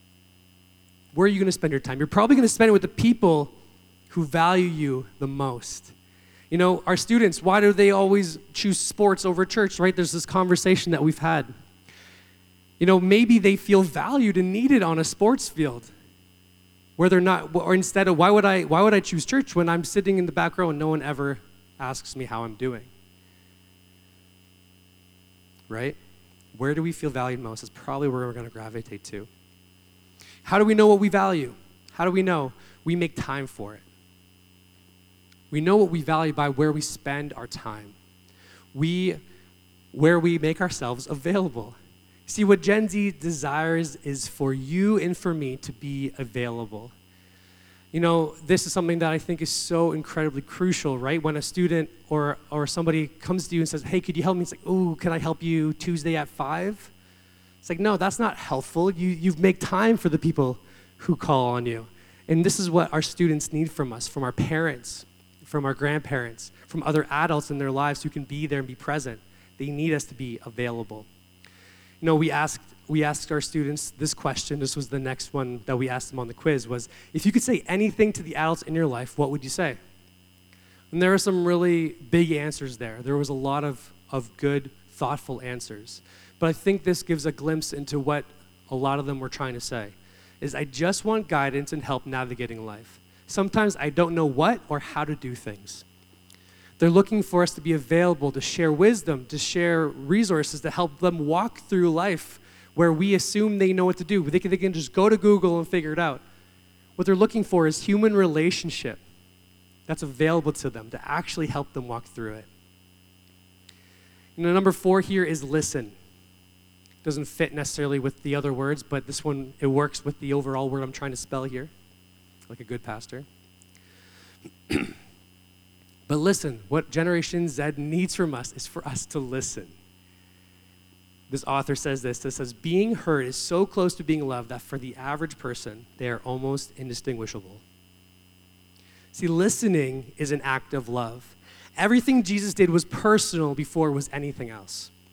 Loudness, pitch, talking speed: -24 LUFS, 140 Hz, 190 wpm